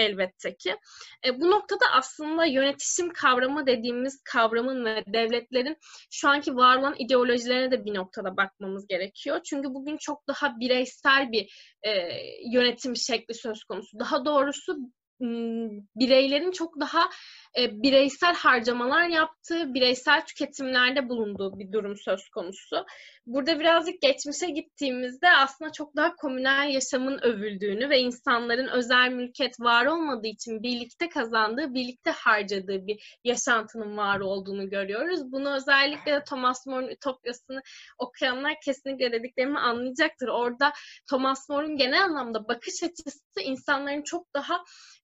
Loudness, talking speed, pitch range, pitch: -26 LUFS, 125 wpm, 240-295 Hz, 265 Hz